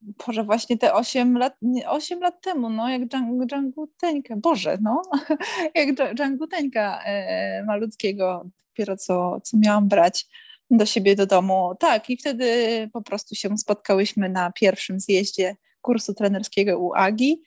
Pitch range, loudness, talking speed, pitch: 200-270 Hz, -22 LUFS, 150 wpm, 225 Hz